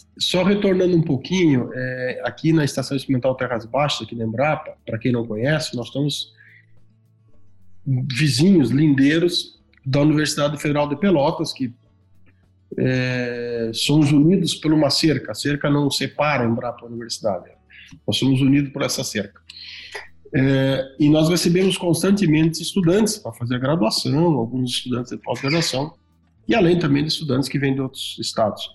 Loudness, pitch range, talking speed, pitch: -20 LUFS, 120-155 Hz, 150 wpm, 135 Hz